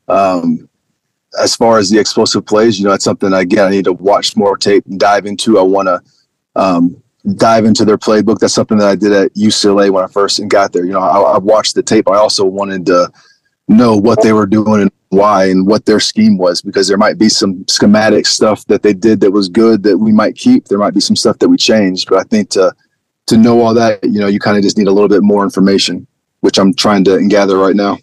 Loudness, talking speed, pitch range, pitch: -10 LUFS, 250 wpm, 100-115 Hz, 105 Hz